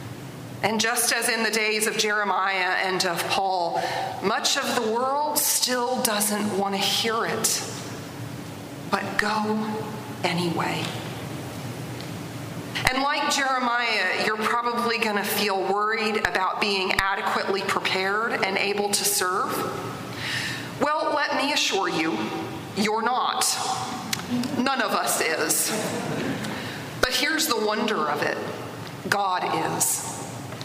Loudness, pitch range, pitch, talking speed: -24 LUFS, 190-240 Hz, 210 Hz, 115 wpm